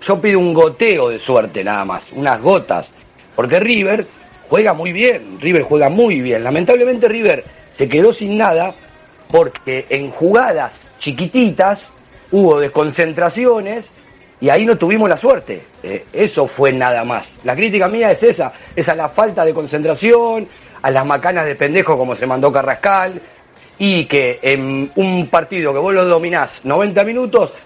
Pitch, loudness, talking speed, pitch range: 190 Hz, -14 LUFS, 160 wpm, 150-230 Hz